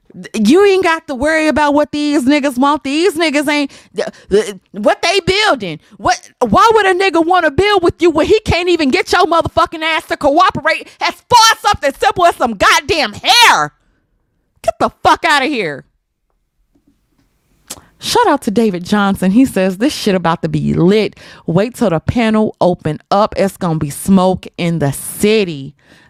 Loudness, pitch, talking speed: -13 LUFS, 290 Hz, 175 wpm